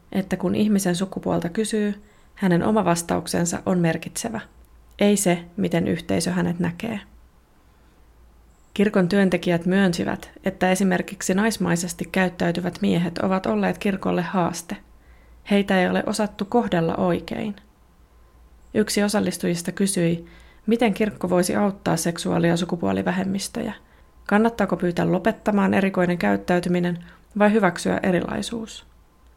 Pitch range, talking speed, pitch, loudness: 170-205 Hz, 105 wpm, 185 Hz, -22 LUFS